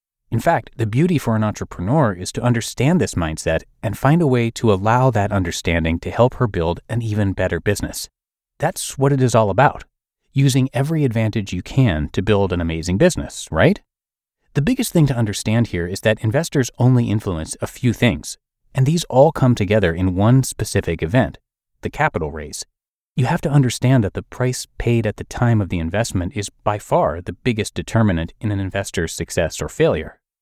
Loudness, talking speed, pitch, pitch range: -19 LUFS, 190 wpm, 110 Hz, 95-130 Hz